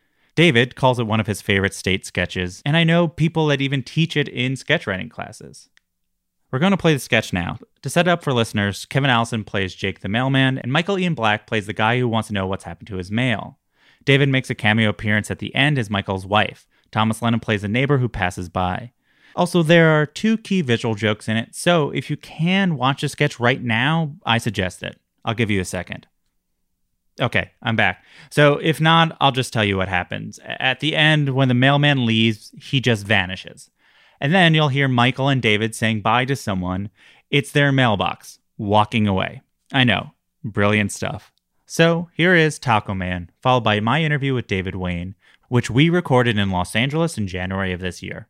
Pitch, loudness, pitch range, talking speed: 120 Hz, -19 LUFS, 100-145 Hz, 205 wpm